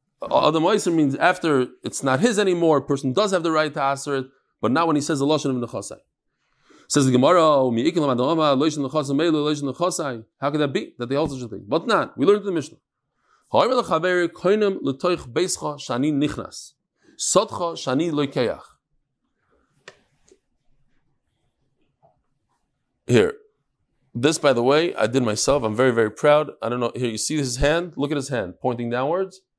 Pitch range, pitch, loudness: 130-170 Hz, 145 Hz, -21 LUFS